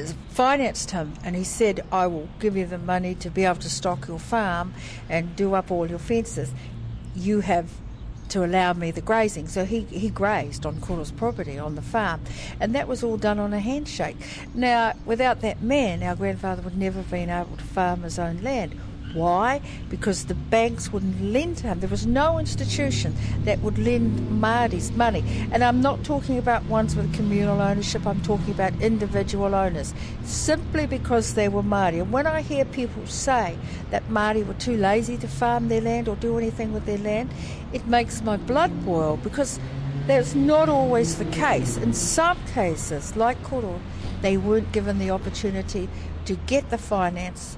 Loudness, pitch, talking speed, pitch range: -24 LUFS, 185 Hz, 185 wpm, 140-225 Hz